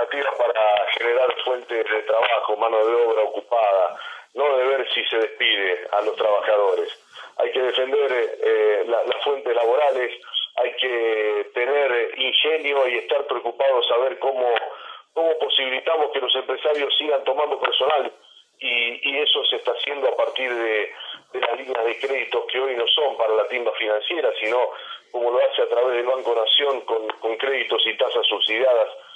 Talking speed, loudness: 165 wpm, -21 LUFS